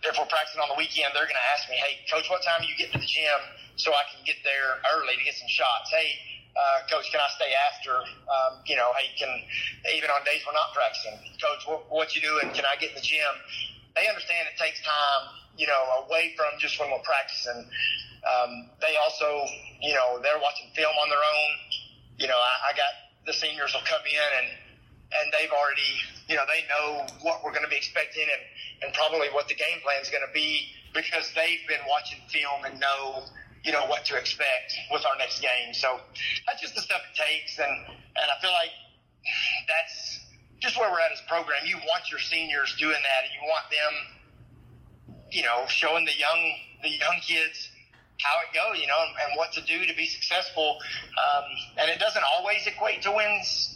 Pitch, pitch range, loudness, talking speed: 150 Hz, 140-165 Hz, -26 LUFS, 215 wpm